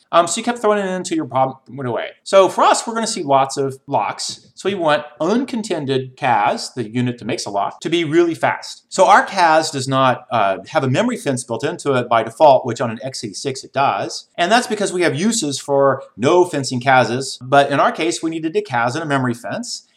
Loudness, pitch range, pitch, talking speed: -18 LUFS, 130-180 Hz, 145 Hz, 235 wpm